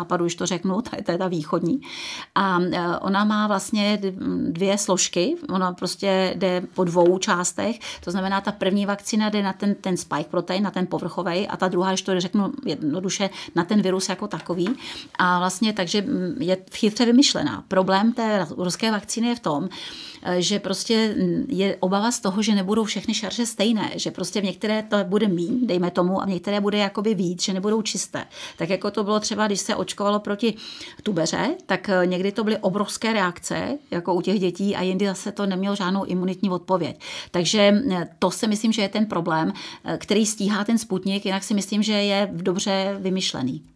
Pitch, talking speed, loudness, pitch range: 195 Hz, 185 wpm, -23 LUFS, 185-215 Hz